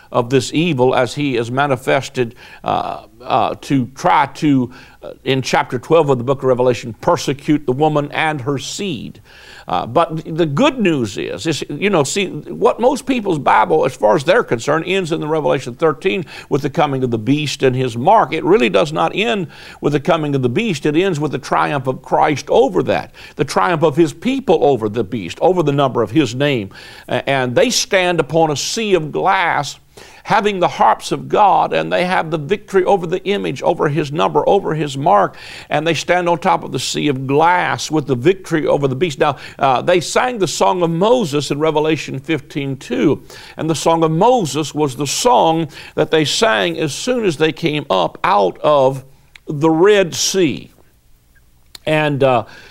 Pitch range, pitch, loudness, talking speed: 135-170 Hz, 155 Hz, -16 LUFS, 195 wpm